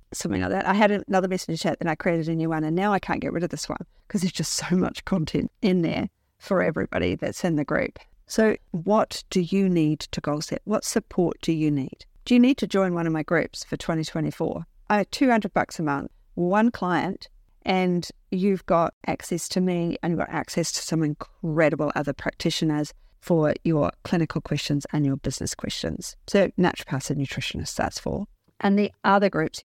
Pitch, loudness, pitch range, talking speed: 175 Hz, -25 LUFS, 155-195 Hz, 205 wpm